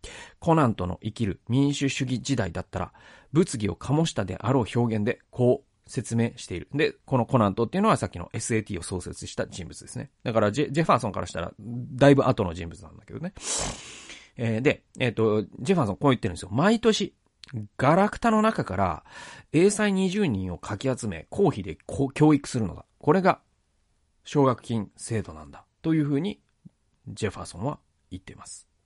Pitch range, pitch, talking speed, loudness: 100-140 Hz, 115 Hz, 370 characters per minute, -26 LUFS